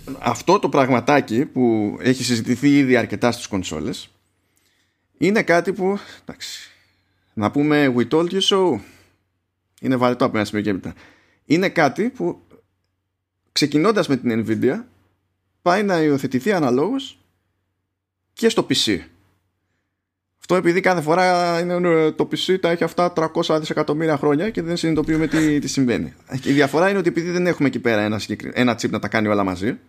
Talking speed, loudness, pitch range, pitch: 155 wpm, -19 LUFS, 100-160 Hz, 125 Hz